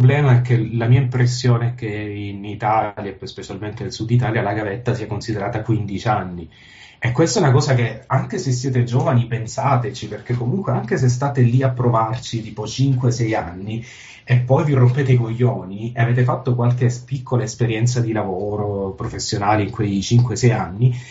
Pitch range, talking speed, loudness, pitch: 105-125 Hz, 180 wpm, -19 LUFS, 120 Hz